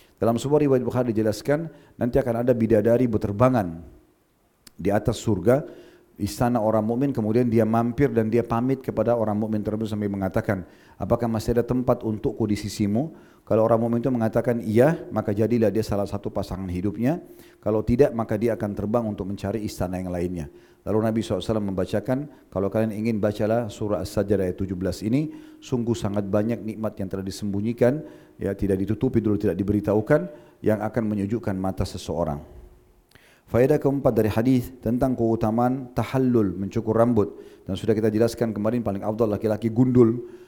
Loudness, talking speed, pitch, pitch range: -24 LUFS, 160 wpm, 110 Hz, 105-120 Hz